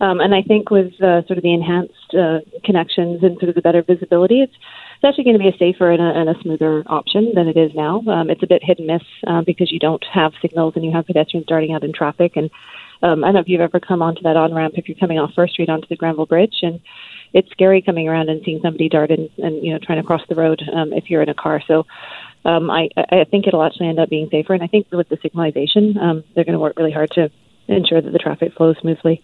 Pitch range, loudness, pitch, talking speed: 160-180 Hz, -16 LUFS, 170 Hz, 275 wpm